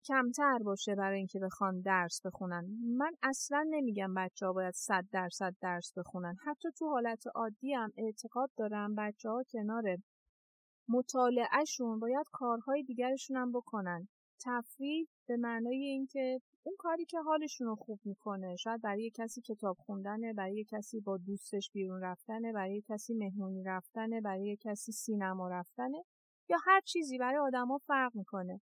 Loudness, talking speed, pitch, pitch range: -37 LUFS, 145 wpm, 225 Hz, 195-255 Hz